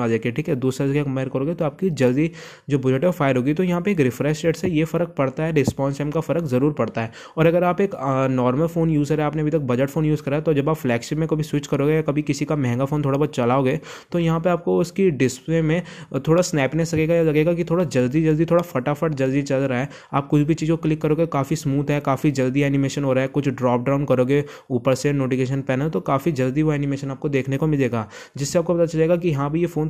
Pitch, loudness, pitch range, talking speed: 145 Hz, -21 LUFS, 135-165 Hz, 225 wpm